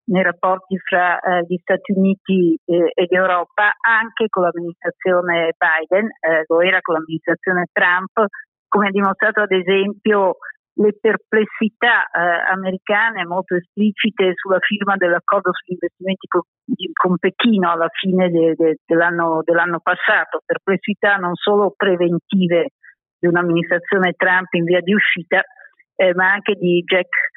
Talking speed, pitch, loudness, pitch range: 135 wpm, 185 Hz, -17 LUFS, 175-200 Hz